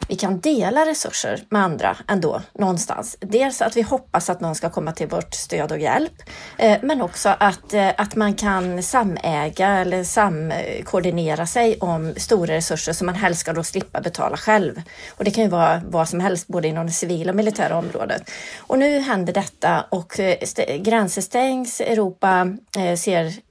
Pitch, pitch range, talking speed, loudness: 195 Hz, 170-220 Hz, 170 wpm, -20 LUFS